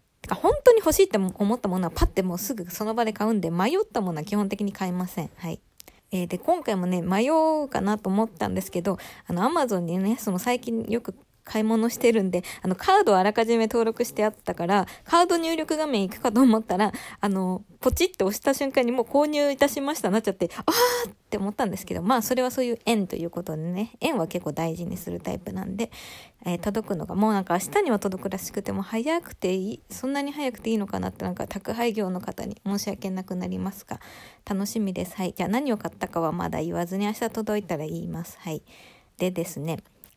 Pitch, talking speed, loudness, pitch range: 210 Hz, 440 characters per minute, -26 LUFS, 185-240 Hz